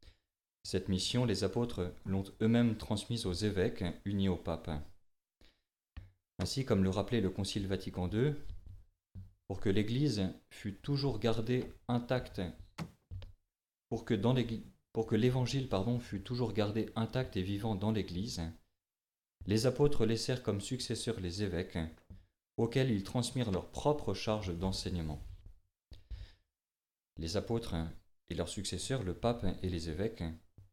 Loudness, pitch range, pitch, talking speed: -36 LUFS, 90-115 Hz, 100 Hz, 130 wpm